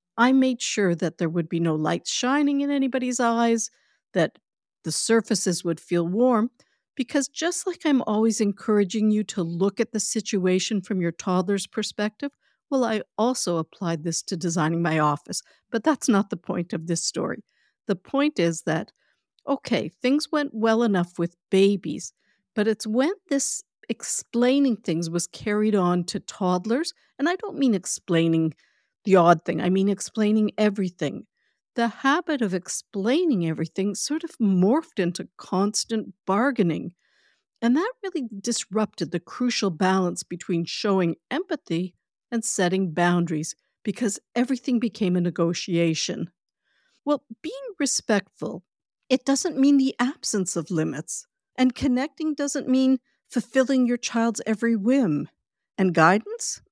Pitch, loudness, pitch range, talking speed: 215 Hz, -24 LUFS, 180-260 Hz, 145 wpm